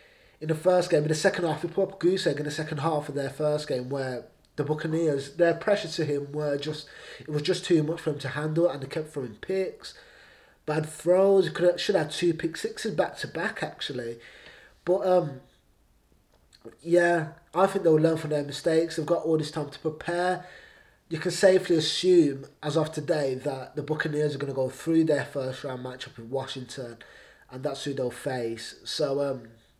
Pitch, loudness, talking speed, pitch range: 155 Hz, -27 LUFS, 210 wpm, 140-170 Hz